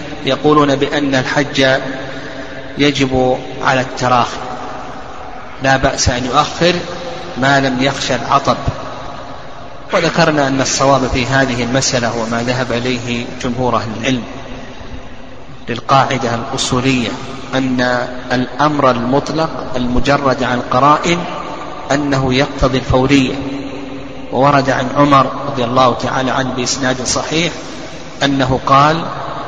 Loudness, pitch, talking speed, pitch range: -14 LUFS, 130 Hz, 100 wpm, 125-140 Hz